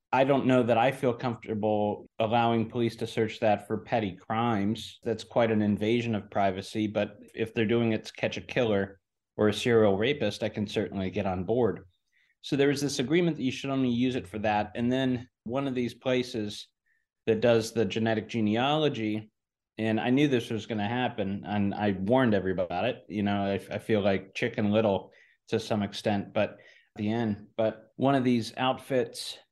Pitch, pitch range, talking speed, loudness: 110 Hz, 105-120 Hz, 195 wpm, -28 LUFS